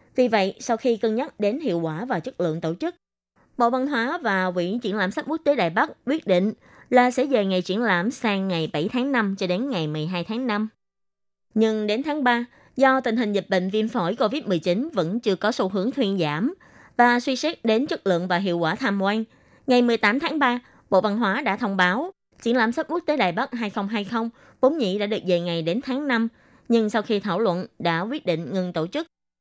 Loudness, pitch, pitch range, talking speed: -23 LUFS, 220 Hz, 190-250 Hz, 230 wpm